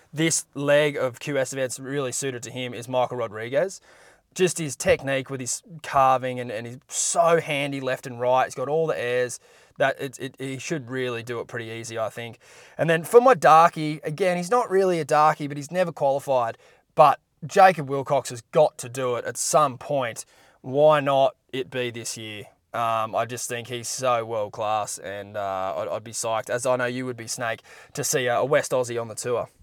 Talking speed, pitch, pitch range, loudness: 210 wpm, 130 Hz, 120-150 Hz, -24 LUFS